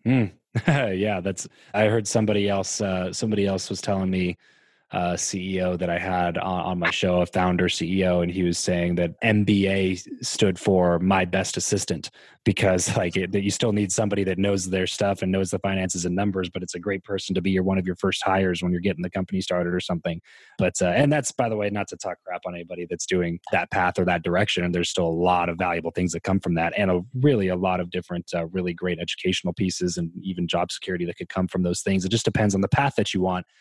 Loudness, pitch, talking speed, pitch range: -24 LUFS, 95 Hz, 245 wpm, 90-100 Hz